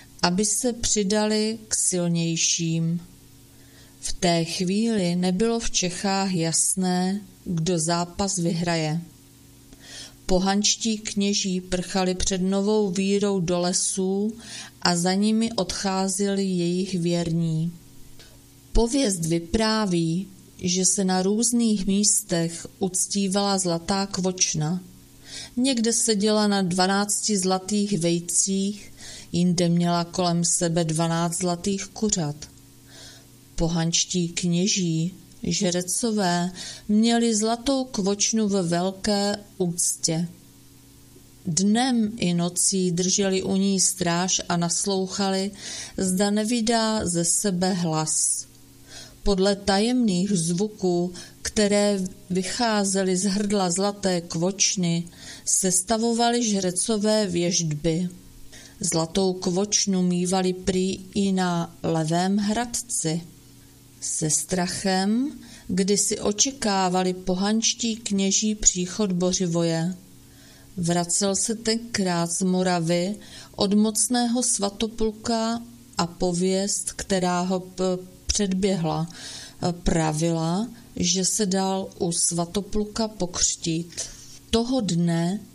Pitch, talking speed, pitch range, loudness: 185 Hz, 90 wpm, 170-205 Hz, -23 LUFS